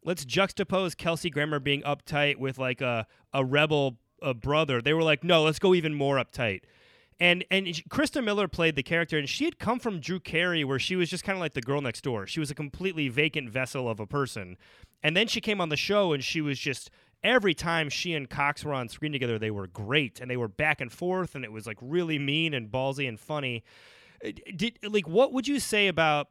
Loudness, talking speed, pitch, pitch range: -28 LUFS, 235 wpm, 150 Hz, 135-180 Hz